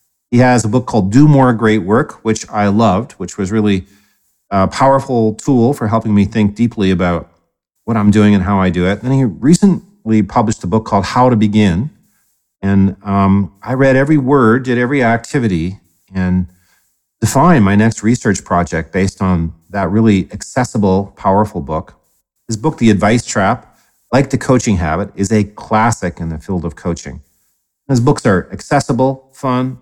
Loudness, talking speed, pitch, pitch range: -14 LUFS, 175 wpm, 105 Hz, 95-125 Hz